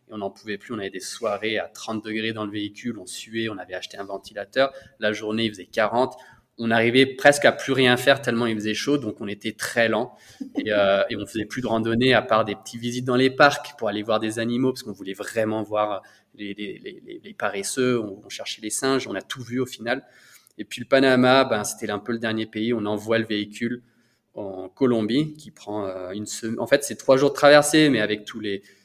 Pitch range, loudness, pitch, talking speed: 105-130 Hz, -23 LUFS, 115 Hz, 240 wpm